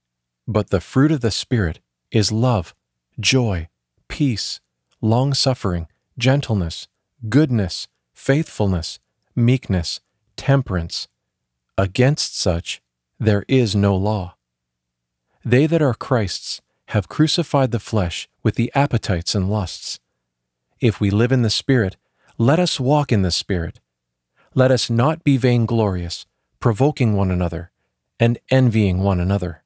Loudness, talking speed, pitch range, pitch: -19 LUFS, 120 wpm, 85-125 Hz, 105 Hz